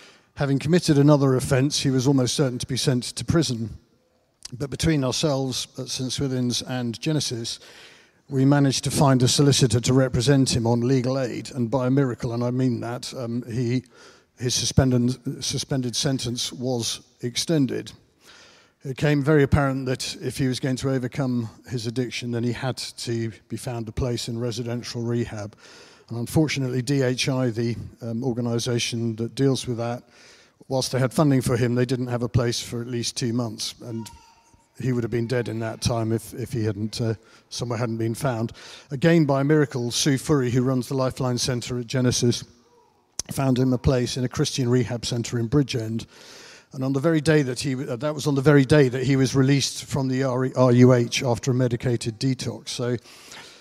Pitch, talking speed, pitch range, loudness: 125 Hz, 185 wpm, 120-135 Hz, -23 LUFS